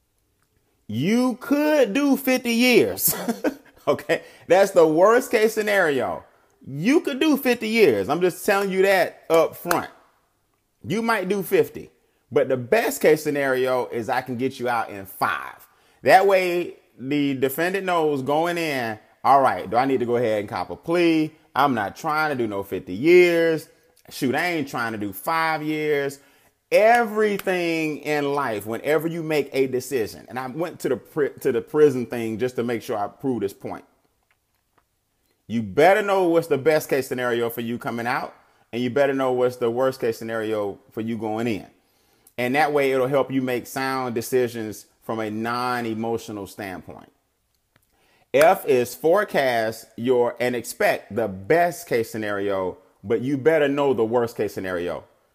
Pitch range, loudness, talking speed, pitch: 120-175 Hz, -22 LUFS, 170 wpm, 140 Hz